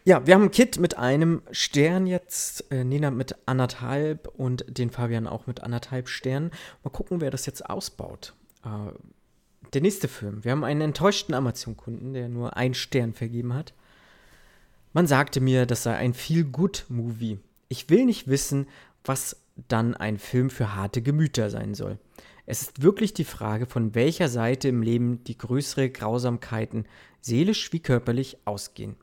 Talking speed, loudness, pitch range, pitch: 160 wpm, -26 LUFS, 115-145 Hz, 130 Hz